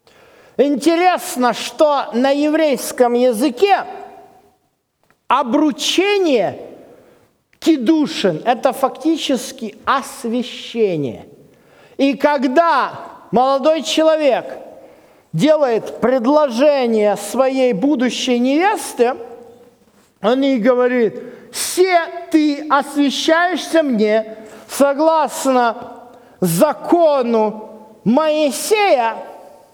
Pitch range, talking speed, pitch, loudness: 240-315 Hz, 60 wpm, 275 Hz, -16 LUFS